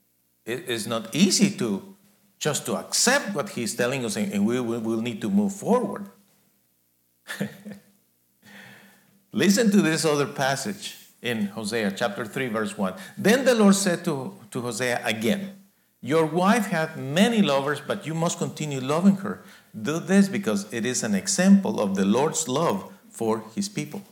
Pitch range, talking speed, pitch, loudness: 130-200 Hz, 160 wpm, 185 Hz, -24 LUFS